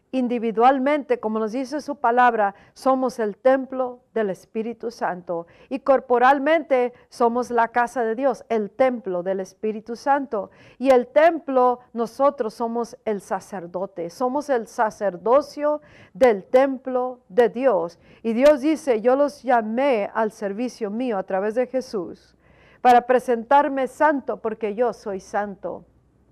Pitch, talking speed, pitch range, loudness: 245 Hz, 130 wpm, 220-260 Hz, -22 LUFS